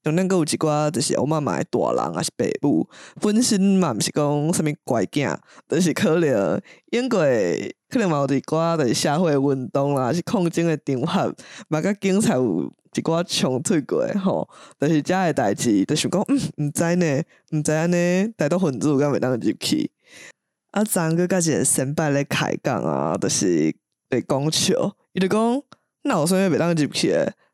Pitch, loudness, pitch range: 165 Hz, -21 LUFS, 145-190 Hz